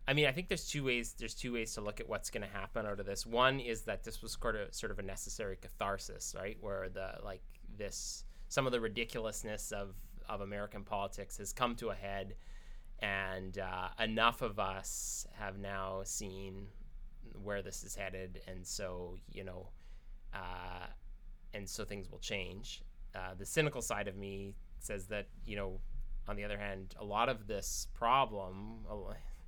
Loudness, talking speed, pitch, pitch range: -40 LUFS, 185 wpm, 100 Hz, 95-110 Hz